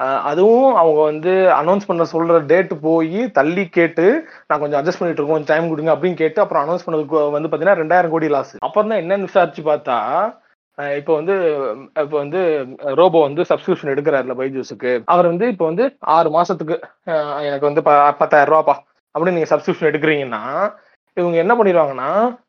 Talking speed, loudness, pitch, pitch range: 160 wpm, -16 LUFS, 165 Hz, 150-185 Hz